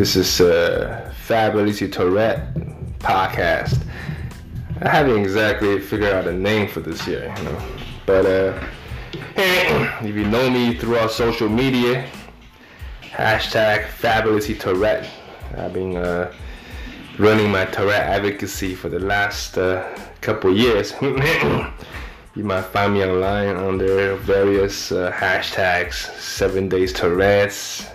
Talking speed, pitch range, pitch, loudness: 120 wpm, 95-110 Hz, 100 Hz, -19 LUFS